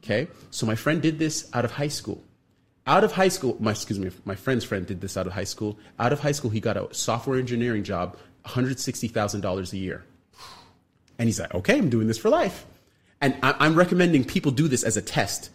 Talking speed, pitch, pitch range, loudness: 220 wpm, 115 Hz, 100-140 Hz, -25 LUFS